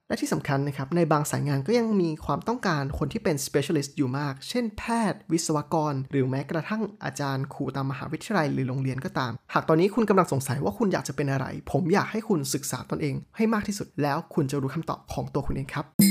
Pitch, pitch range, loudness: 150 Hz, 140-185 Hz, -27 LUFS